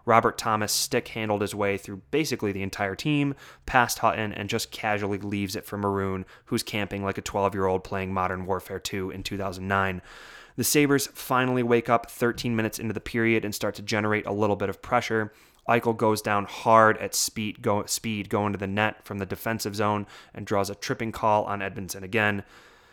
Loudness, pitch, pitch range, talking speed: -26 LUFS, 105 Hz, 100-115 Hz, 195 wpm